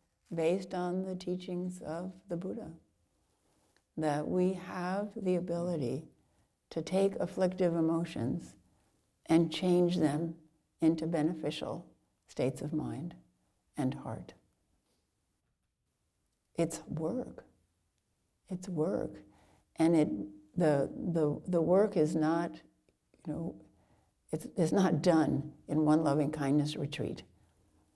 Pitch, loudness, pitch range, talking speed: 160 Hz, -33 LUFS, 140-180 Hz, 105 wpm